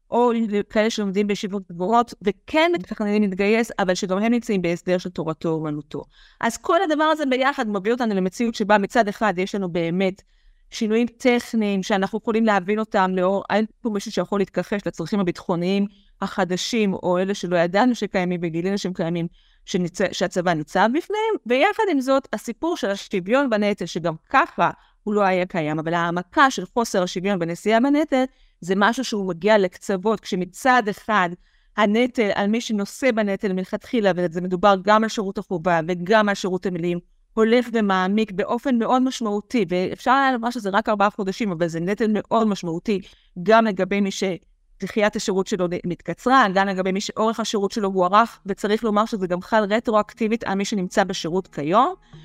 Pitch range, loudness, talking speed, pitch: 185-225 Hz, -21 LUFS, 165 wpm, 205 Hz